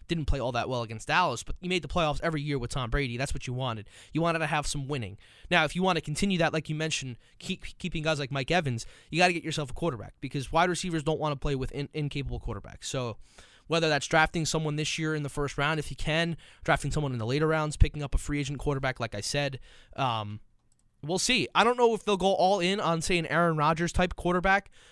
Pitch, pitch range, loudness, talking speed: 150 Hz, 135-165 Hz, -29 LUFS, 260 wpm